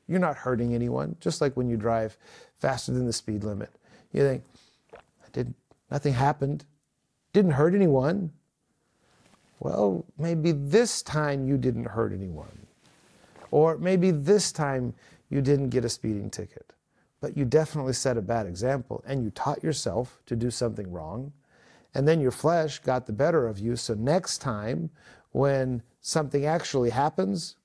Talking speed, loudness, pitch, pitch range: 155 wpm, -27 LUFS, 135 Hz, 120-155 Hz